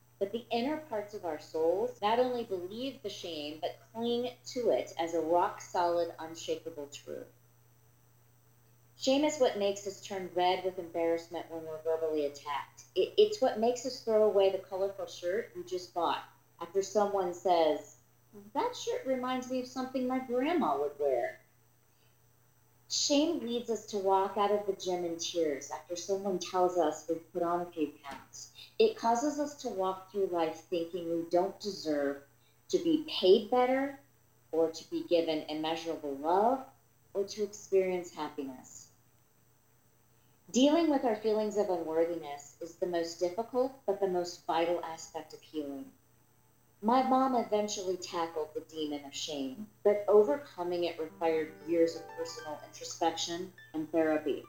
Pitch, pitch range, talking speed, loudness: 175 Hz, 155-215 Hz, 155 wpm, -33 LUFS